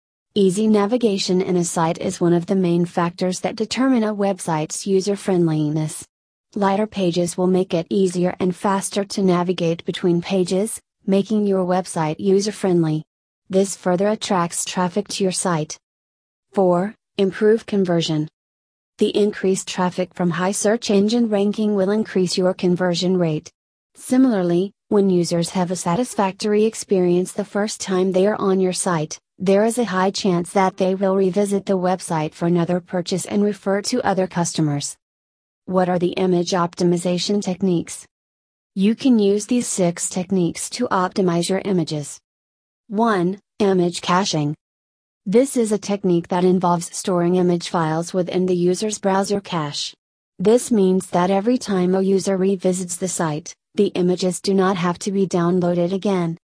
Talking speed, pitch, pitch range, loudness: 150 wpm, 185 Hz, 175-200 Hz, -20 LUFS